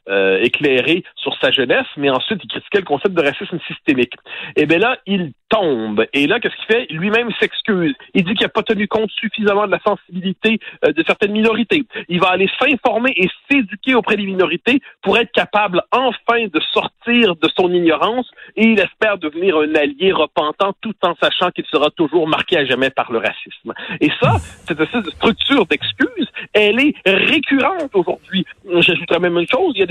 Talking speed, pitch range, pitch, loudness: 190 wpm, 170-225 Hz, 200 Hz, -16 LUFS